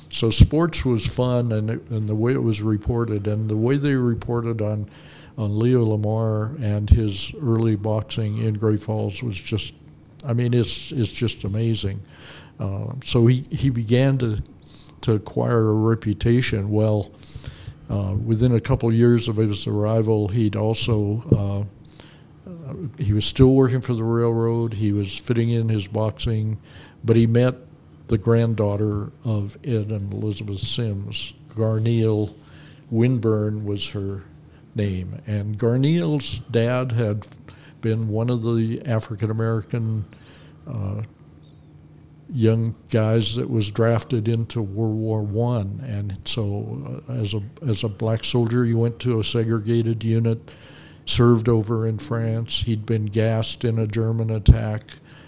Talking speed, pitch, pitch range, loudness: 145 wpm, 115 Hz, 105-120 Hz, -22 LUFS